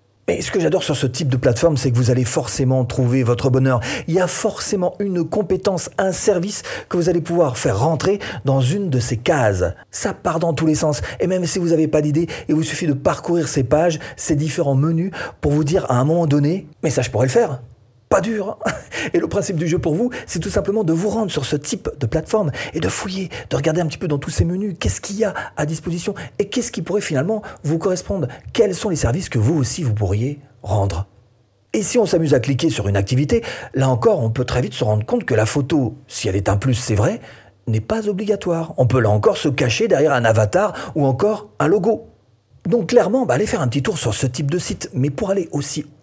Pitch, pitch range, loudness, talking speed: 150 Hz, 125-180 Hz, -19 LUFS, 245 wpm